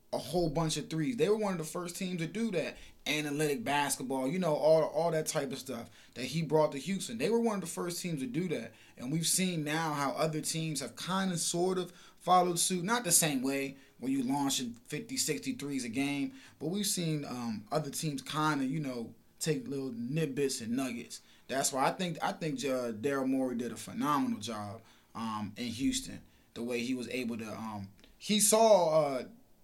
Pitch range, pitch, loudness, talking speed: 130-175 Hz, 150 Hz, -32 LUFS, 215 wpm